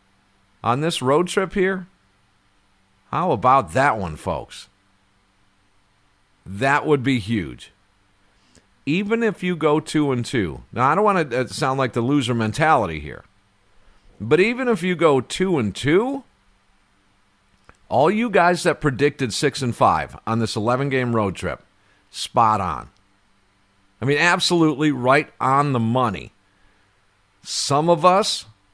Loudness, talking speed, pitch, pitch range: -20 LUFS, 140 wpm, 120 Hz, 100-150 Hz